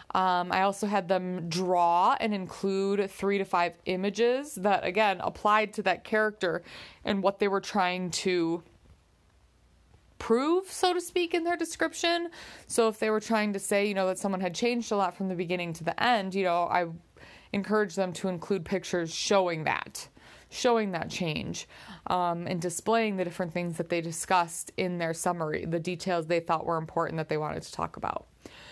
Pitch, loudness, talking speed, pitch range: 185 Hz, -29 LUFS, 190 wpm, 175-210 Hz